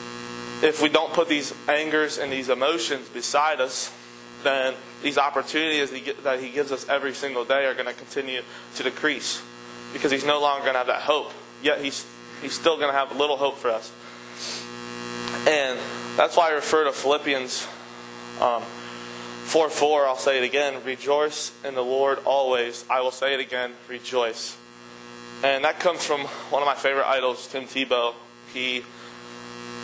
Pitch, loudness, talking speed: 125 Hz, -24 LUFS, 170 wpm